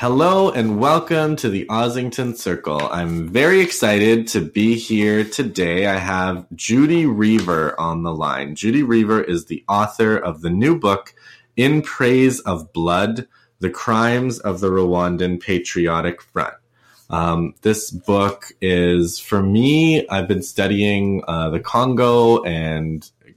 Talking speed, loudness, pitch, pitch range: 140 wpm, -18 LUFS, 100 Hz, 90-120 Hz